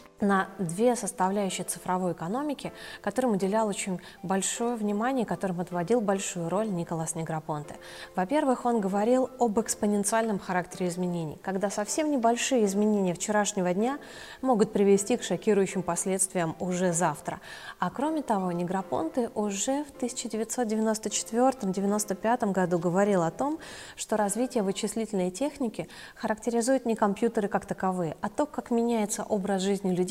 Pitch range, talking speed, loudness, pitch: 185-235 Hz, 125 wpm, -28 LUFS, 205 Hz